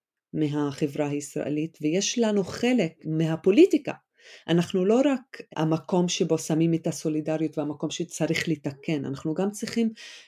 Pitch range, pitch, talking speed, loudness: 155-200 Hz, 165 Hz, 115 wpm, -26 LUFS